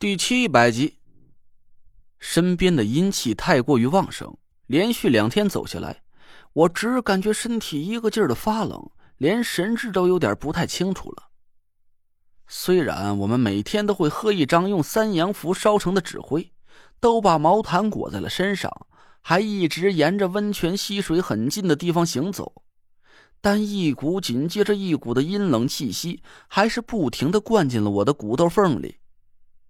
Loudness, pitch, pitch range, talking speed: -22 LUFS, 180 Hz, 135-205 Hz, 235 characters per minute